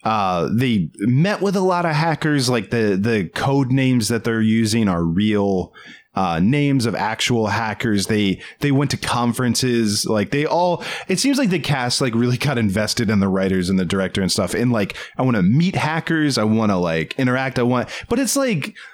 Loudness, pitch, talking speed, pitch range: -19 LUFS, 120 Hz, 205 wpm, 105-145 Hz